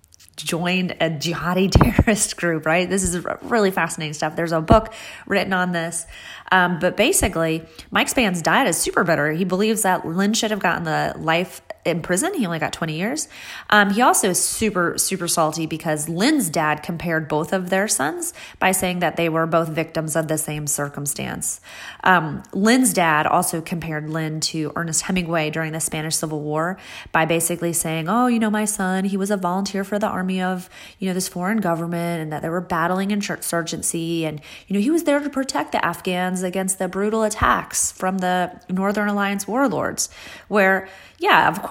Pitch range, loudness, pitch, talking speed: 165-205 Hz, -20 LUFS, 180 Hz, 190 wpm